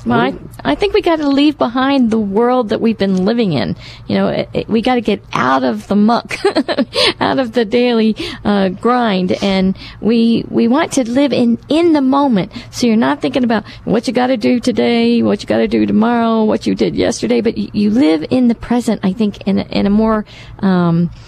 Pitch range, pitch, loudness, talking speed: 195-250 Hz, 225 Hz, -14 LUFS, 225 wpm